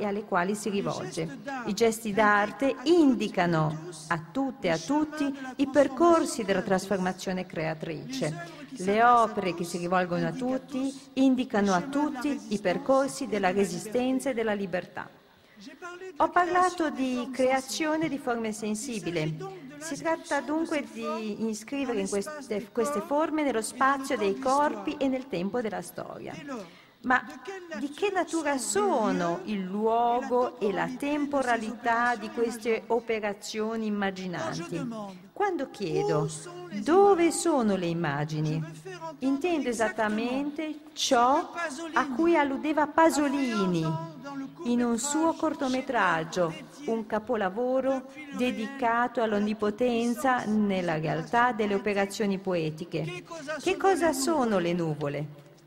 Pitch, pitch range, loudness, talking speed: 235 Hz, 195-280 Hz, -28 LUFS, 115 wpm